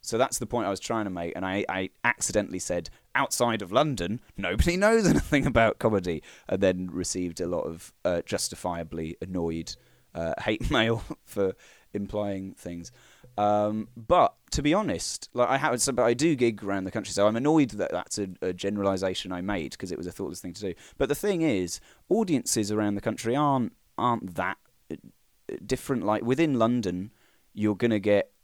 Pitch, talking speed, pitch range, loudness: 105 Hz, 185 wpm, 90-120 Hz, -27 LUFS